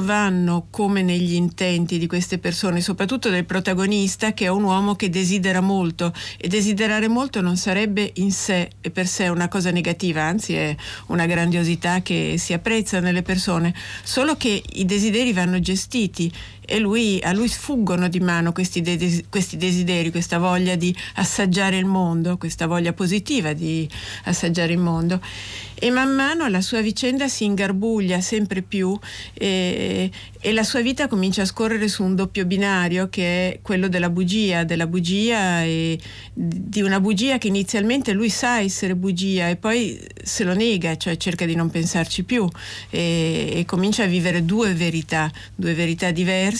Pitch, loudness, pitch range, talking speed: 185 Hz, -21 LUFS, 175-205 Hz, 165 wpm